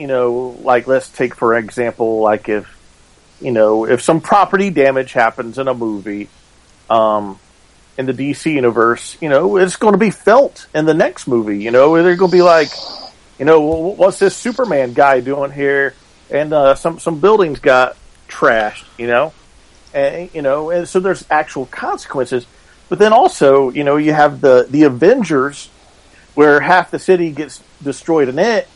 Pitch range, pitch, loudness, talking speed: 120-160 Hz, 135 Hz, -13 LUFS, 175 wpm